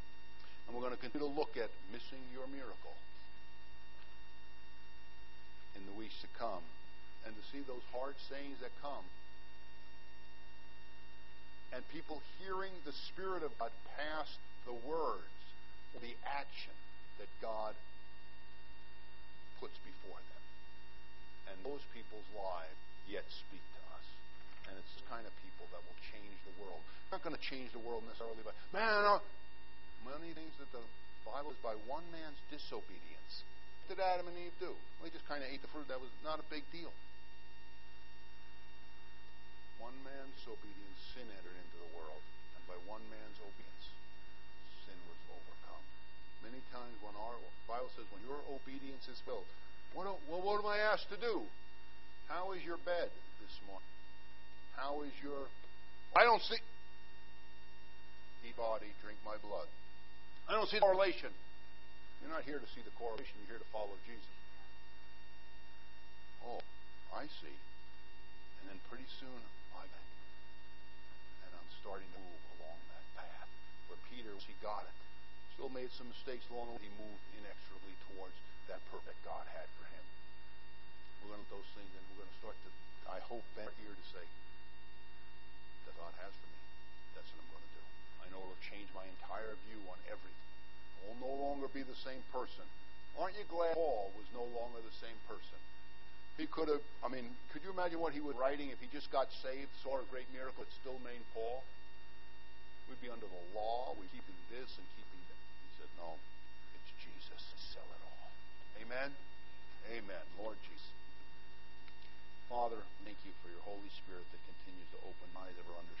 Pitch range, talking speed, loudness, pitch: 90-135 Hz, 170 wpm, -45 LUFS, 110 Hz